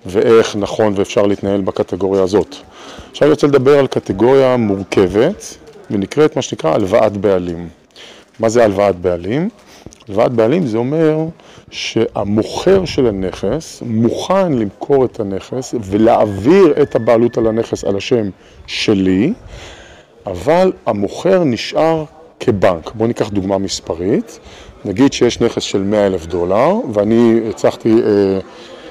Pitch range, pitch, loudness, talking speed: 100-135 Hz, 115 Hz, -14 LUFS, 120 wpm